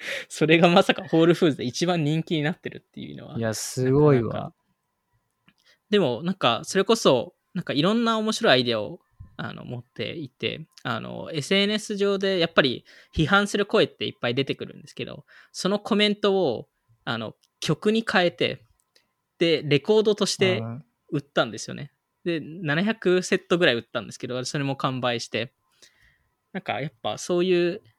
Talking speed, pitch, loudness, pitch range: 340 characters per minute, 175 Hz, -24 LUFS, 140-200 Hz